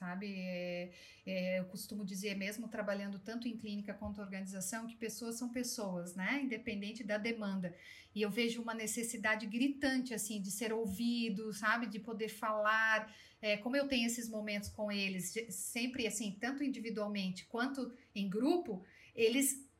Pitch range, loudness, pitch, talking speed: 205-235 Hz, -38 LUFS, 220 Hz, 155 wpm